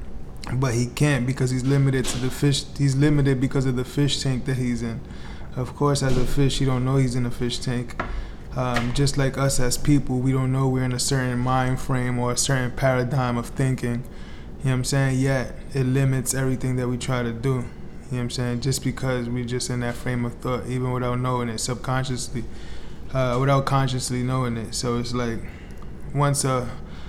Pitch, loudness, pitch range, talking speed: 125 Hz, -24 LUFS, 120-135 Hz, 215 wpm